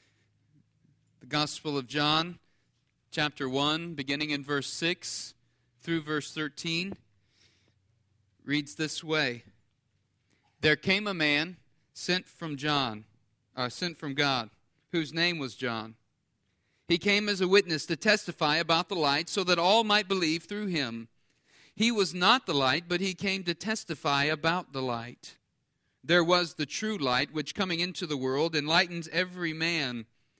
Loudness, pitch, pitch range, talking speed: -29 LUFS, 150 Hz, 125-170 Hz, 145 wpm